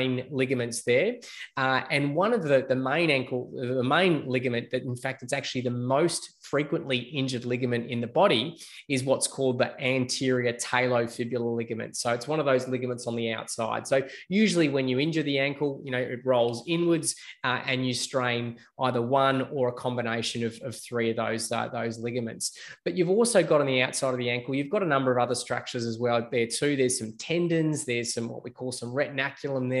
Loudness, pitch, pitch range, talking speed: -27 LUFS, 130 Hz, 120-140 Hz, 210 wpm